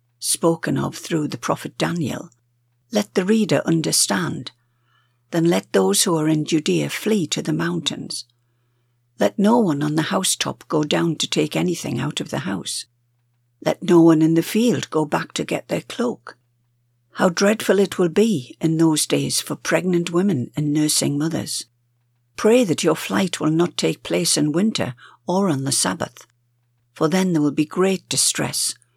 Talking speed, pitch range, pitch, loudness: 170 wpm, 120-175 Hz, 155 Hz, -20 LUFS